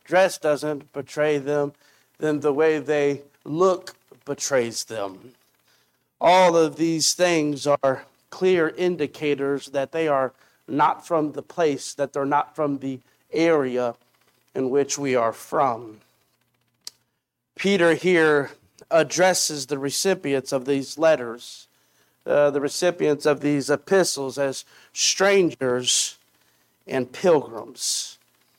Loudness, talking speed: -22 LUFS, 115 wpm